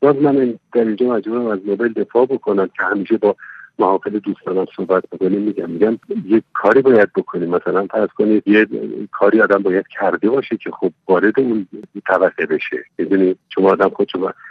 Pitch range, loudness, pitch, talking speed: 105-135 Hz, -17 LUFS, 115 Hz, 180 wpm